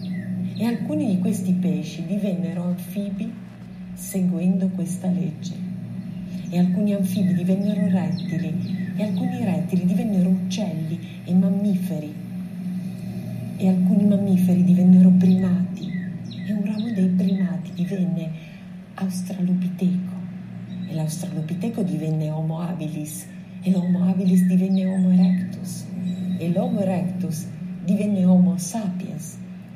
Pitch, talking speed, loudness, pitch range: 185 Hz, 105 wpm, -22 LUFS, 180-185 Hz